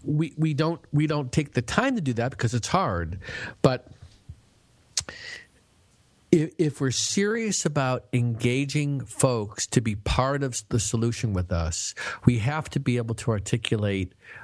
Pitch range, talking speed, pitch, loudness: 115-150 Hz, 155 wpm, 125 Hz, -26 LUFS